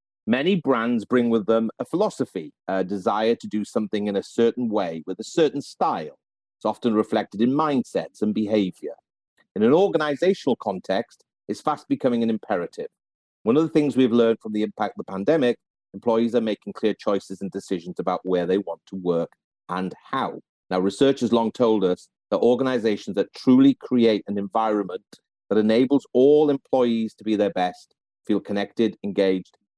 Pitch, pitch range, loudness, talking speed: 110 Hz, 100-125 Hz, -23 LUFS, 175 wpm